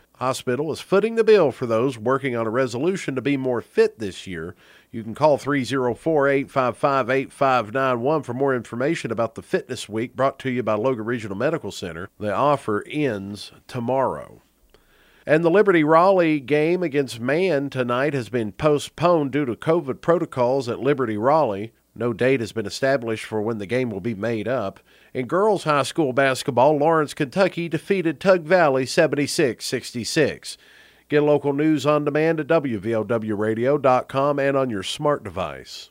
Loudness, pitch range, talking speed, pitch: -21 LUFS, 115-150 Hz, 160 wpm, 135 Hz